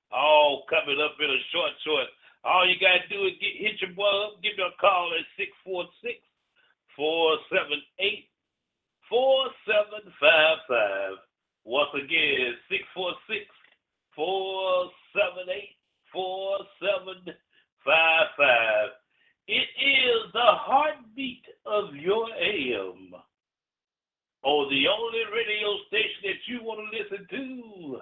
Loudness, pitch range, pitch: -25 LUFS, 175-270 Hz, 205 Hz